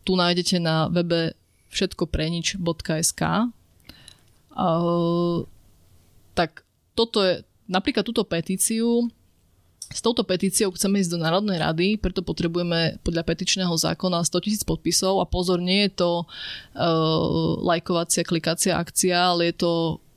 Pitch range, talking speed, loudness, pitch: 165-190 Hz, 120 wpm, -23 LUFS, 175 Hz